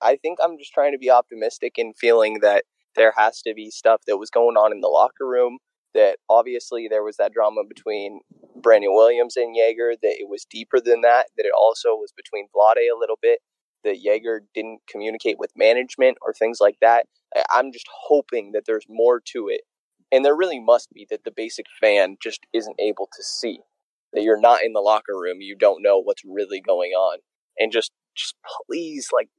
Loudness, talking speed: -20 LUFS, 205 wpm